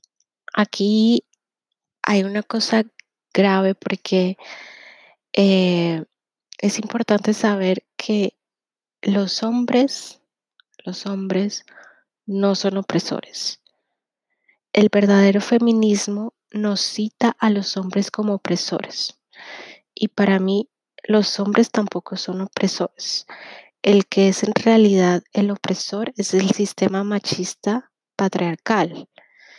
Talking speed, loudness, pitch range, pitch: 95 wpm, -20 LUFS, 190-215 Hz, 200 Hz